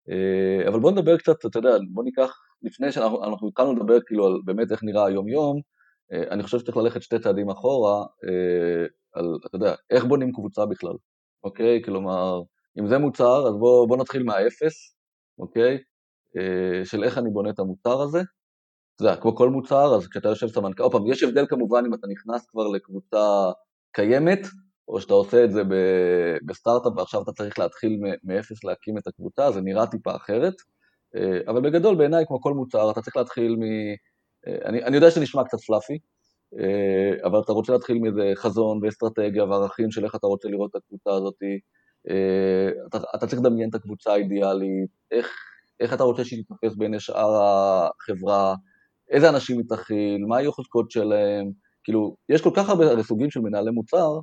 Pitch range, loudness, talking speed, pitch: 100-125 Hz, -23 LUFS, 175 wpm, 110 Hz